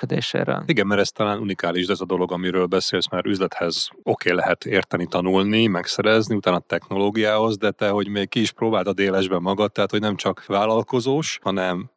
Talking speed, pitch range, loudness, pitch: 185 wpm, 95-110 Hz, -21 LUFS, 100 Hz